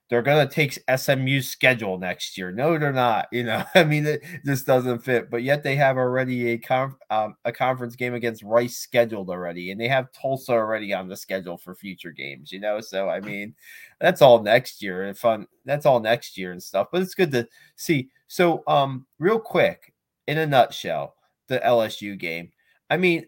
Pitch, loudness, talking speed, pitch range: 120 Hz, -23 LUFS, 205 wpm, 105-140 Hz